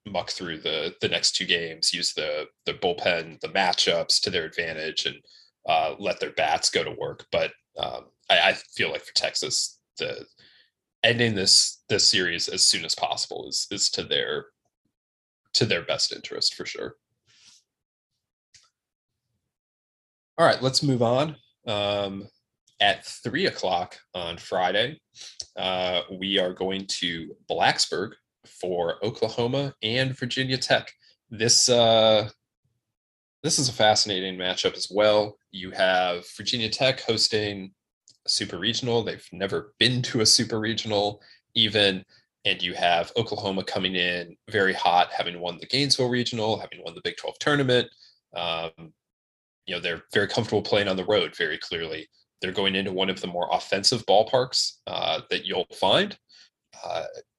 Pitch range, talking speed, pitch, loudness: 95-130 Hz, 150 wpm, 110 Hz, -24 LUFS